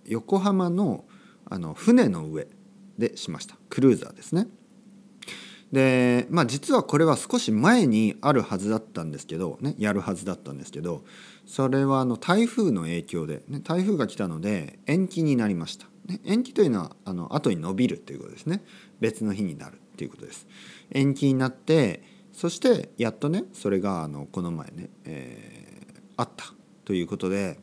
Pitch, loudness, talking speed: 150 Hz, -25 LUFS, 345 characters per minute